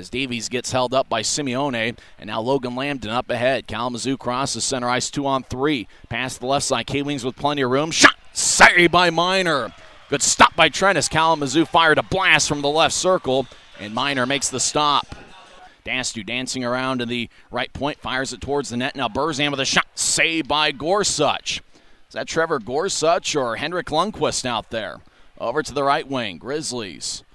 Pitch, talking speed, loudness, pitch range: 135 Hz, 190 wpm, -20 LUFS, 125-150 Hz